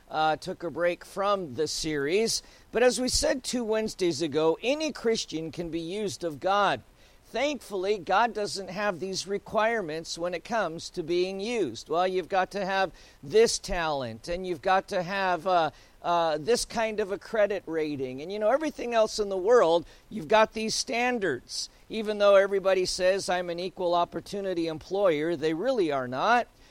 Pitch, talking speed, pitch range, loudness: 190 Hz, 175 wpm, 170-215 Hz, -27 LUFS